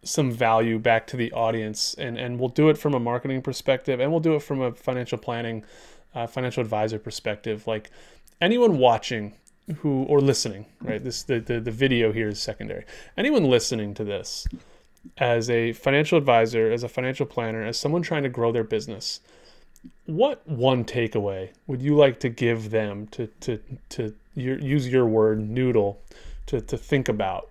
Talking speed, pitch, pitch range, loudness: 180 wpm, 120 Hz, 110-135 Hz, -24 LUFS